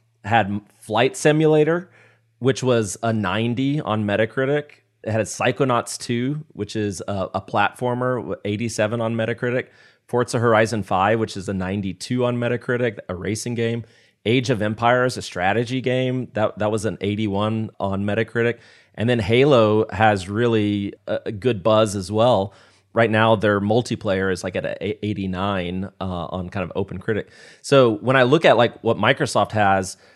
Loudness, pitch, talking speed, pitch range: -21 LUFS, 110 Hz, 165 wpm, 100-125 Hz